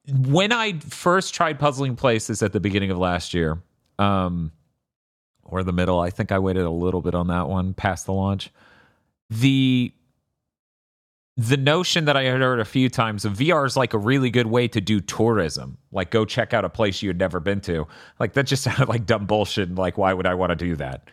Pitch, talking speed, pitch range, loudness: 105 Hz, 220 wpm, 90-130 Hz, -22 LUFS